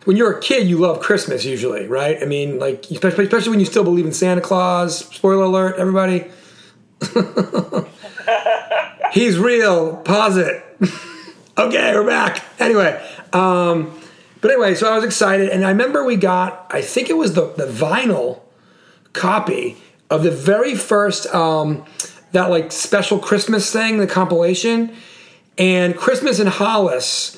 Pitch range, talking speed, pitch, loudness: 175-210 Hz, 145 wpm, 185 Hz, -17 LUFS